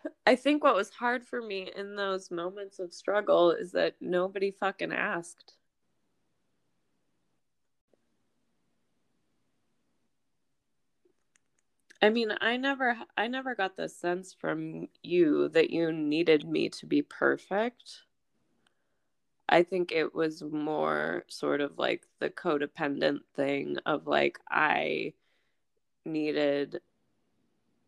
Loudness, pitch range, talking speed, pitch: -30 LUFS, 150-210 Hz, 110 wpm, 180 Hz